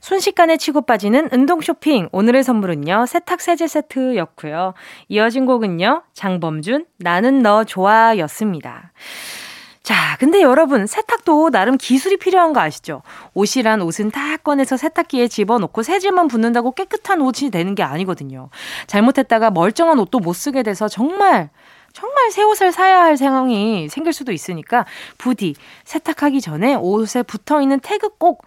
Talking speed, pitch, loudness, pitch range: 335 characters per minute, 260 Hz, -16 LUFS, 210-320 Hz